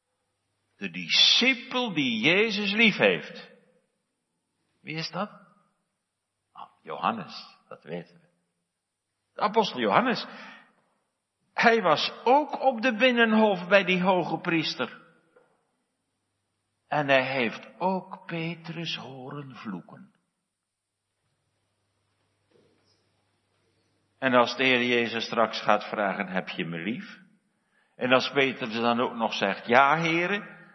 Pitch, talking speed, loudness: 135 Hz, 105 wpm, -24 LUFS